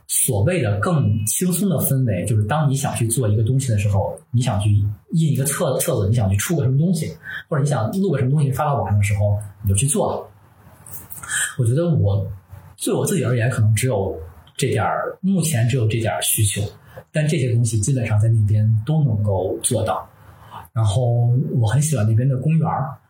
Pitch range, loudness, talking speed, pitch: 105-140 Hz, -20 LUFS, 295 characters per minute, 120 Hz